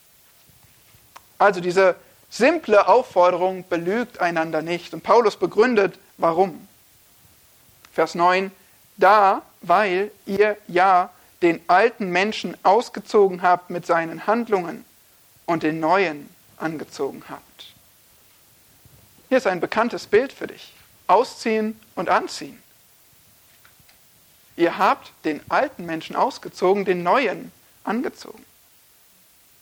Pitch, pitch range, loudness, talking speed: 185 Hz, 170-210 Hz, -21 LUFS, 100 wpm